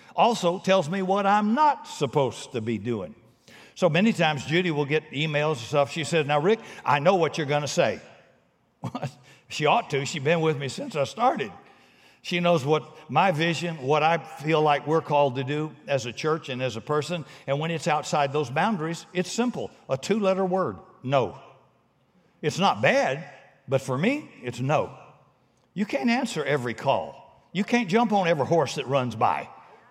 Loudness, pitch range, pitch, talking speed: -25 LUFS, 140-180 Hz, 155 Hz, 190 wpm